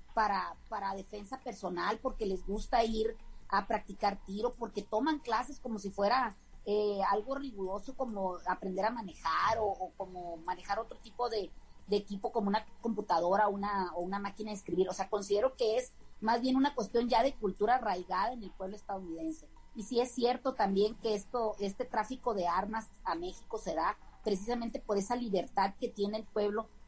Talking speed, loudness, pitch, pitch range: 185 wpm, -35 LUFS, 210 Hz, 195-235 Hz